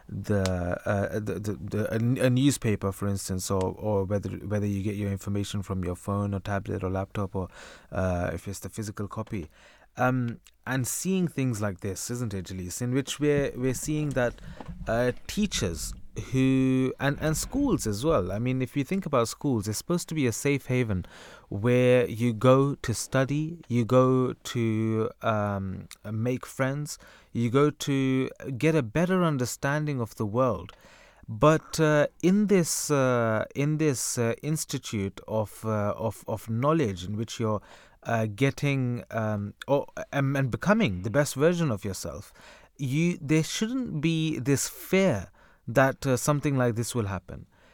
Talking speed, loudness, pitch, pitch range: 165 wpm, -27 LUFS, 120 Hz, 105-140 Hz